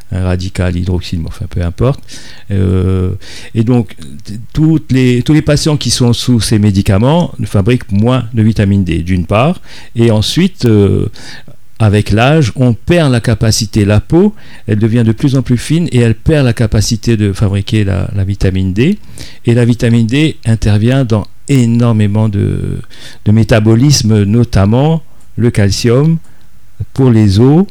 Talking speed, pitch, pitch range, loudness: 155 wpm, 115 Hz, 105-130 Hz, -11 LUFS